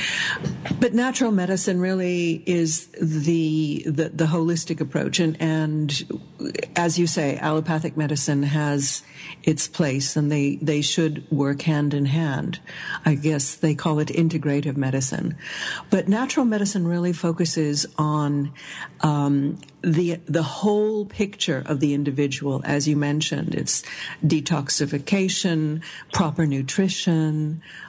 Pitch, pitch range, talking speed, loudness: 155 Hz, 145-170 Hz, 120 wpm, -23 LUFS